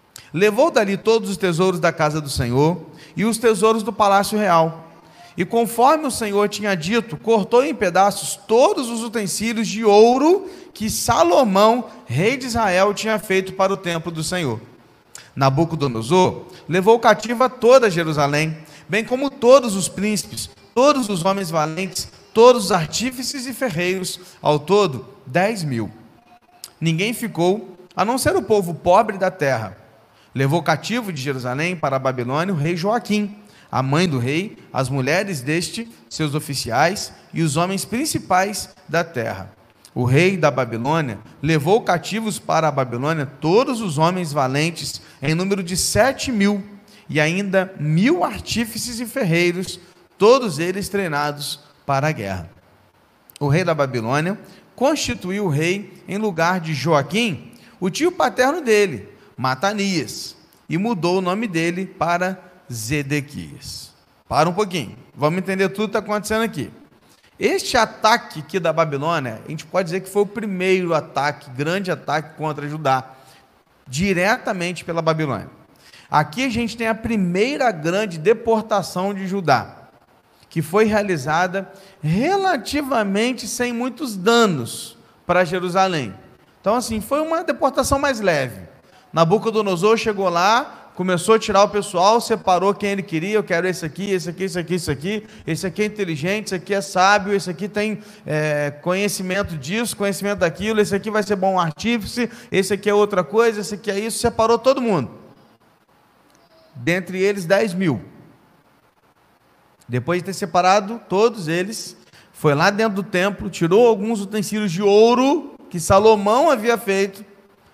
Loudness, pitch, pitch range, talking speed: -19 LUFS, 190 Hz, 160-215 Hz, 150 wpm